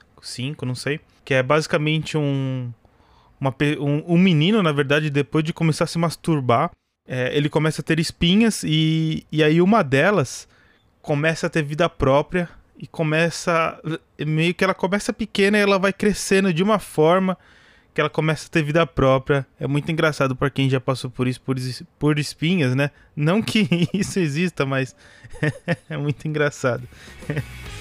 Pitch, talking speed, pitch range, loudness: 155 Hz, 165 wpm, 135-170 Hz, -21 LUFS